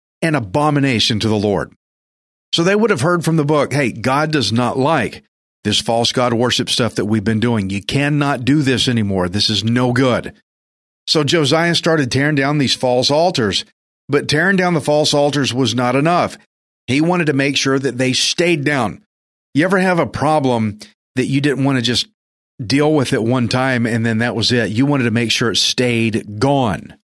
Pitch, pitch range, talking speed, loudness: 130 Hz, 115-150 Hz, 200 wpm, -16 LUFS